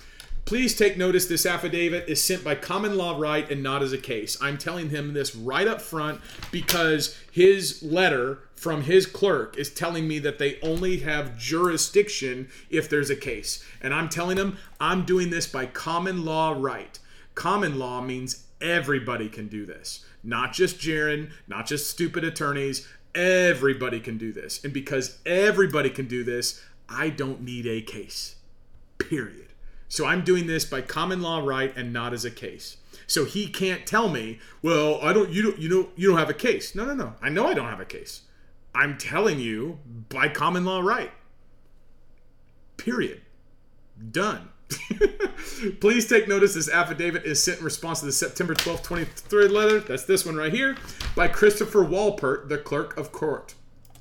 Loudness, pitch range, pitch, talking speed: -25 LUFS, 135-185 Hz, 160 Hz, 175 wpm